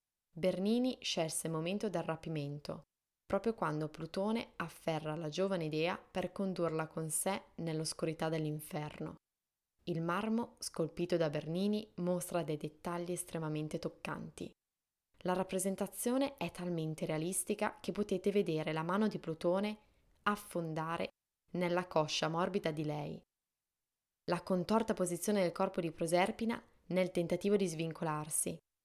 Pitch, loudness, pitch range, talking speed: 175 Hz, -37 LUFS, 160-195 Hz, 120 wpm